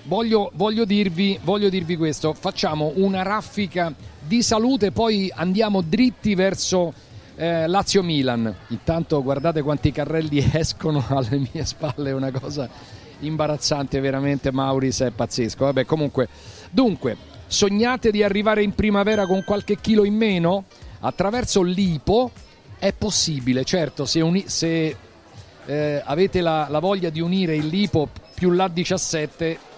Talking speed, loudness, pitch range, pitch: 135 wpm, -21 LUFS, 140-195 Hz, 165 Hz